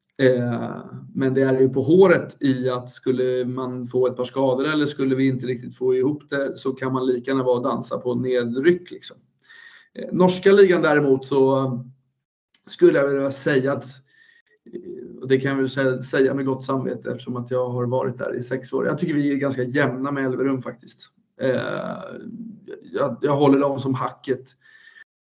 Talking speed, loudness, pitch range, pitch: 175 wpm, -21 LUFS, 130-145 Hz, 135 Hz